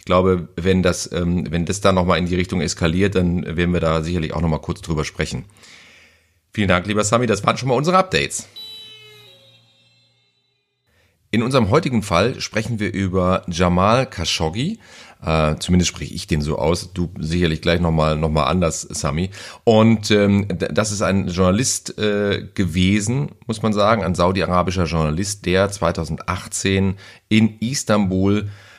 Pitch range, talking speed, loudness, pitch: 85-110 Hz, 145 wpm, -19 LUFS, 95 Hz